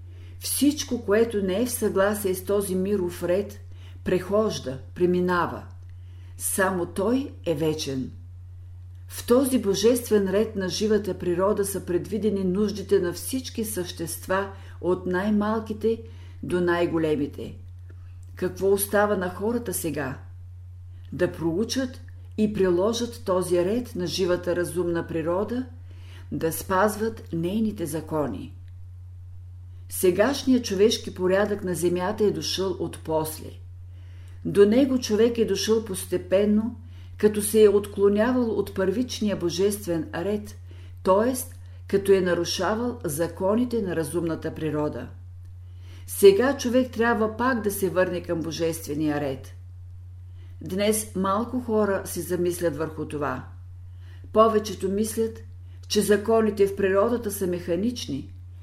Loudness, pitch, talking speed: -25 LUFS, 175 Hz, 110 wpm